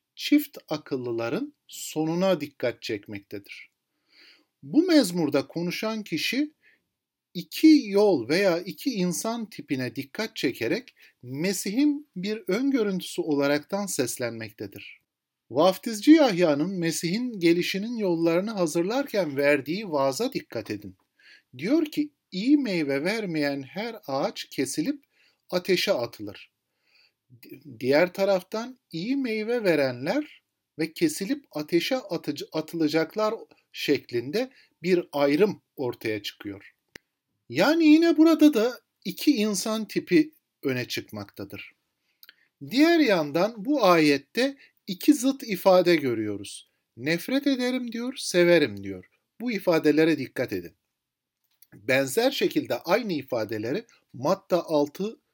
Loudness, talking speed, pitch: -25 LUFS, 100 wpm, 180 Hz